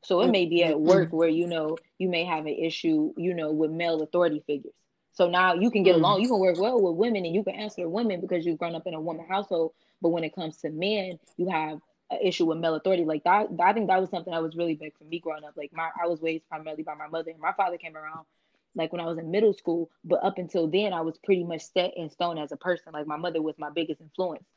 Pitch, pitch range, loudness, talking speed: 170 Hz, 160-185 Hz, -27 LUFS, 280 wpm